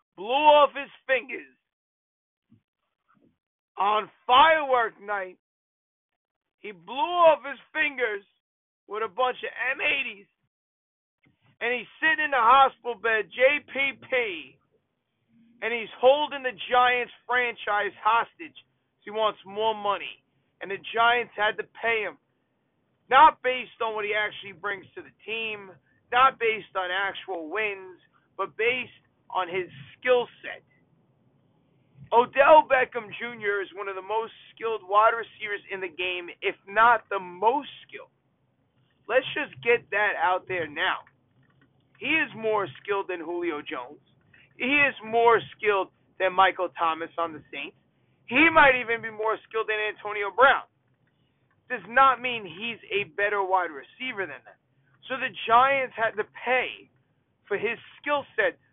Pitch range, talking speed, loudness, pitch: 190-255 Hz, 140 wpm, -25 LUFS, 220 Hz